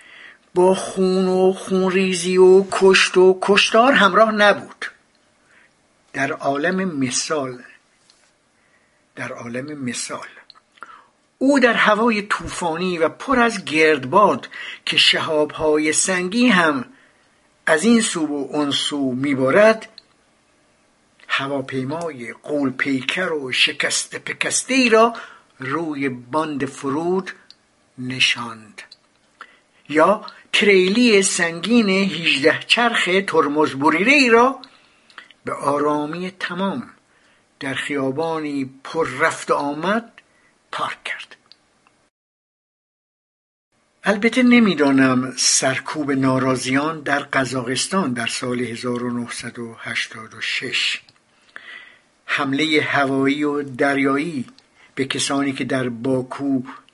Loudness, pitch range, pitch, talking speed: -18 LUFS, 135-195 Hz, 155 Hz, 85 wpm